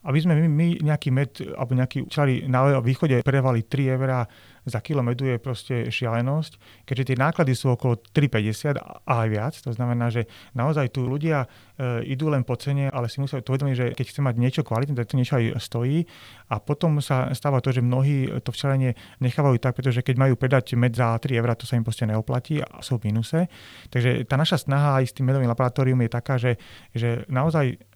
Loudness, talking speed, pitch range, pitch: -24 LUFS, 200 wpm, 120-140 Hz, 130 Hz